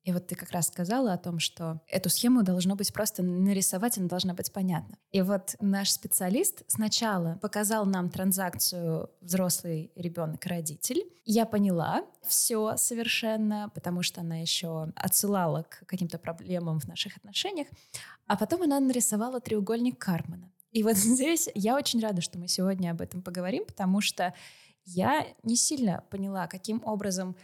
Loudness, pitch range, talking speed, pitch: -29 LUFS, 175-220 Hz, 155 wpm, 190 Hz